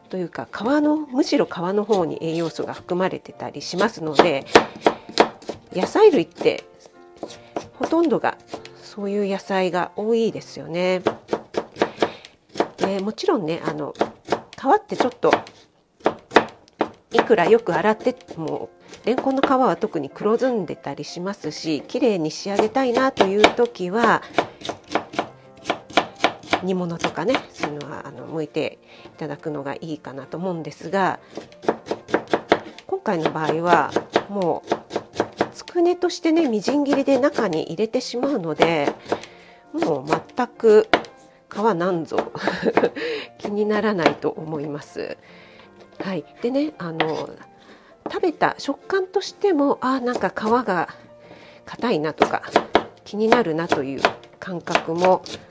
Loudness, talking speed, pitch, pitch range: -22 LUFS, 245 characters per minute, 200 Hz, 155-255 Hz